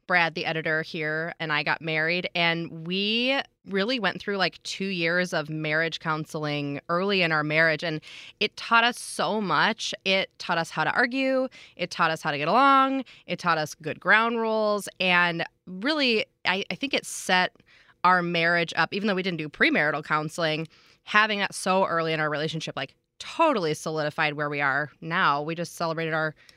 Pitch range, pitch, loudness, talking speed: 155-195 Hz, 170 Hz, -25 LUFS, 185 wpm